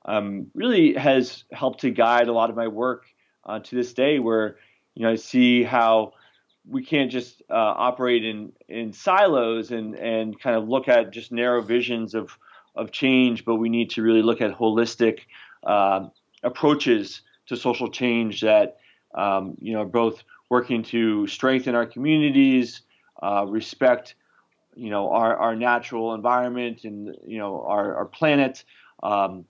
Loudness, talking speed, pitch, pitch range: -22 LUFS, 160 wpm, 120 Hz, 110-125 Hz